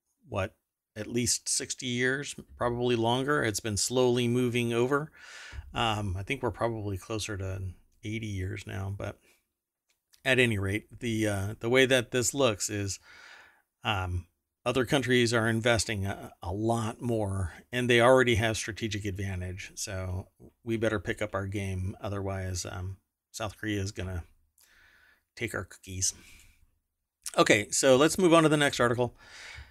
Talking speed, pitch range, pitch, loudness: 150 wpm, 95-120 Hz, 110 Hz, -29 LUFS